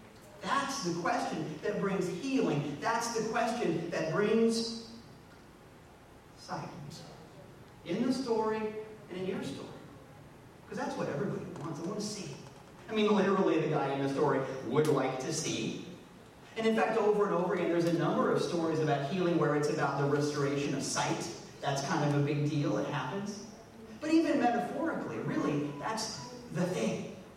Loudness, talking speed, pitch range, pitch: -32 LUFS, 165 wpm, 150-215 Hz, 180 Hz